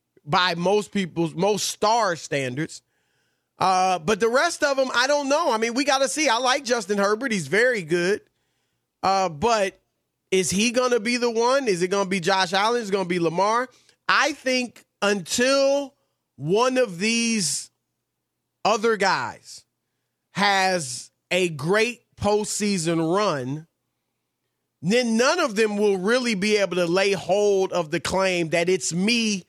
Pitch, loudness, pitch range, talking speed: 205 Hz, -22 LUFS, 185-240 Hz, 155 wpm